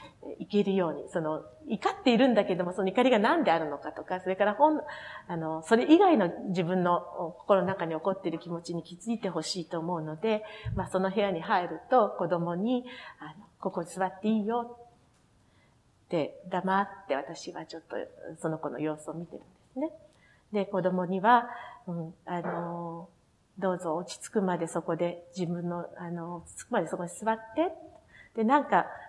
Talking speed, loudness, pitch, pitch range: 330 characters per minute, -30 LUFS, 185 Hz, 170-225 Hz